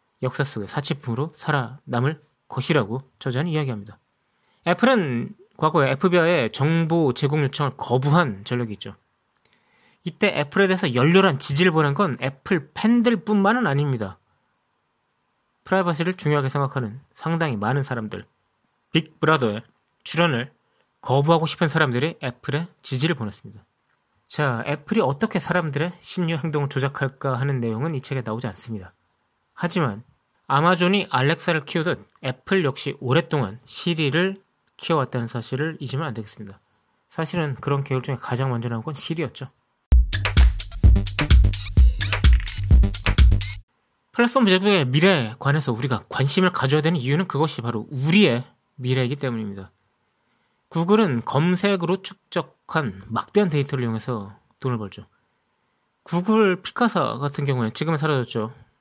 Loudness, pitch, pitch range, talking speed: -22 LUFS, 140 Hz, 120-165 Hz, 320 characters per minute